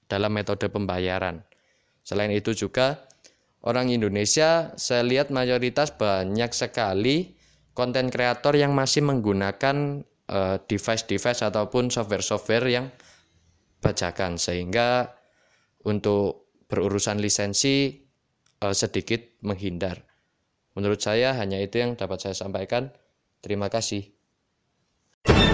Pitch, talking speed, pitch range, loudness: 105 Hz, 95 wpm, 100-125 Hz, -25 LUFS